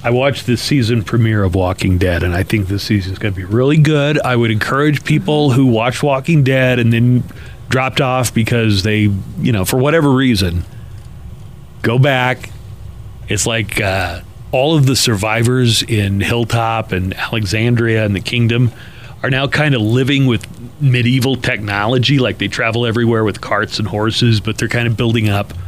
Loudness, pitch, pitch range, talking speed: -14 LUFS, 115 Hz, 105-130 Hz, 175 wpm